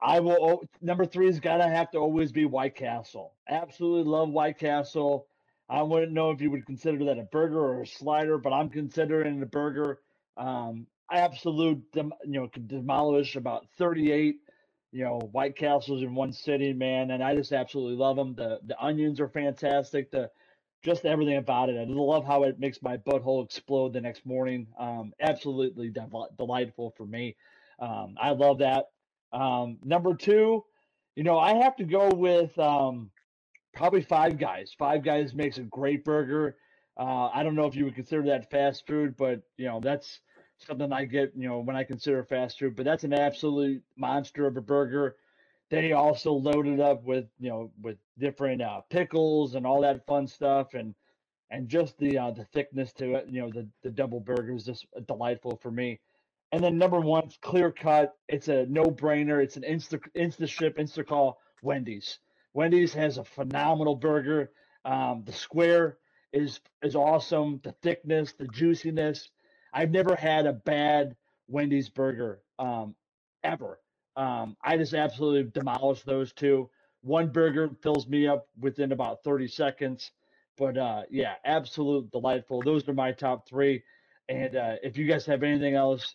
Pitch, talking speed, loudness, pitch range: 140 Hz, 175 wpm, -28 LUFS, 130-155 Hz